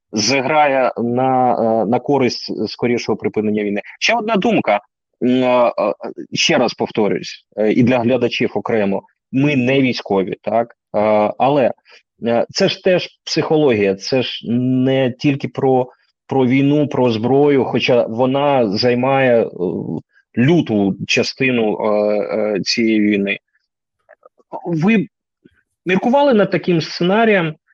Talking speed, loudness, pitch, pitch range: 100 wpm, -16 LUFS, 130 Hz, 115-145 Hz